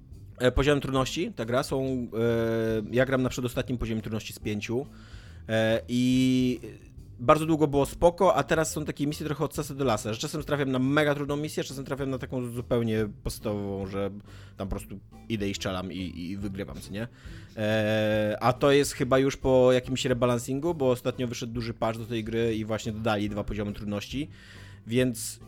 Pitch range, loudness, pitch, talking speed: 105-130 Hz, -28 LUFS, 120 Hz, 180 wpm